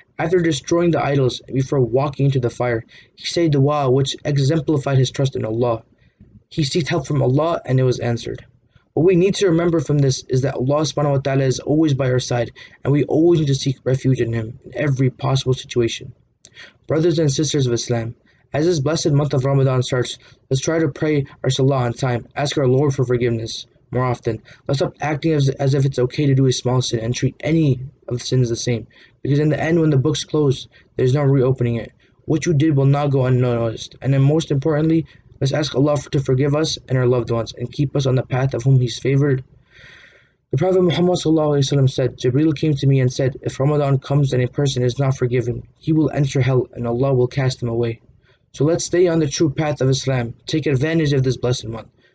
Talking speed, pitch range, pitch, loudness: 220 wpm, 125-150 Hz, 135 Hz, -19 LUFS